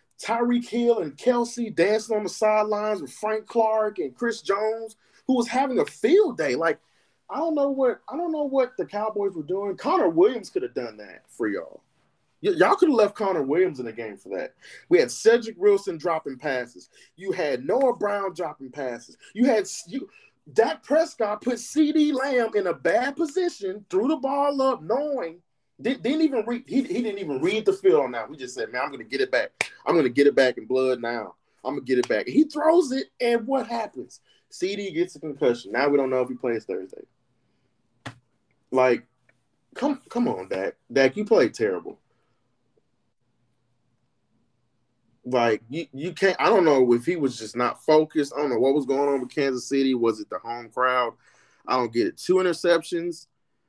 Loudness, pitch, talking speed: -24 LUFS, 205 Hz, 200 wpm